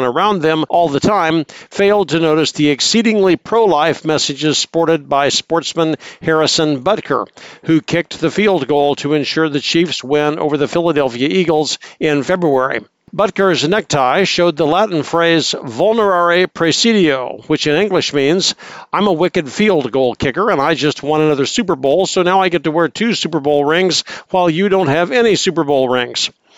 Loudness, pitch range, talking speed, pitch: -14 LUFS, 150-185 Hz, 175 wpm, 165 Hz